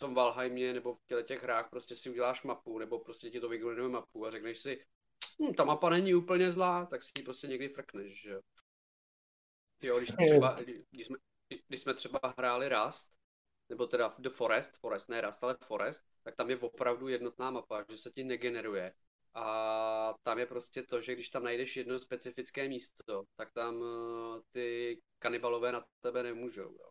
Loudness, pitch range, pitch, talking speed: -36 LUFS, 115-130 Hz, 125 Hz, 185 wpm